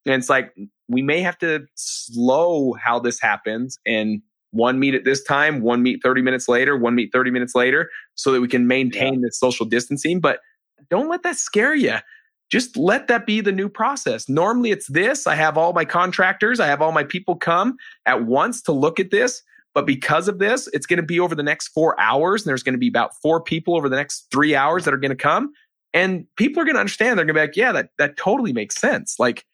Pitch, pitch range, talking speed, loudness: 155 Hz, 125-200 Hz, 240 wpm, -19 LUFS